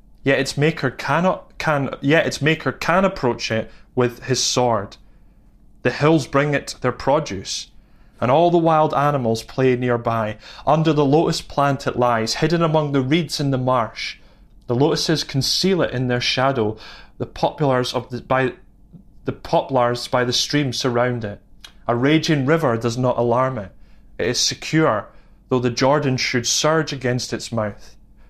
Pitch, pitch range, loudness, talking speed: 130 Hz, 120-145 Hz, -20 LUFS, 165 wpm